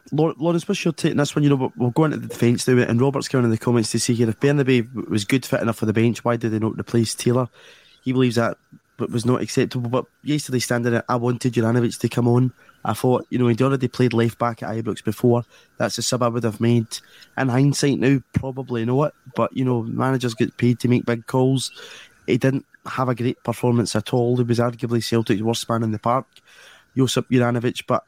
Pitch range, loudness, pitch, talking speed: 115-130 Hz, -21 LUFS, 120 Hz, 220 wpm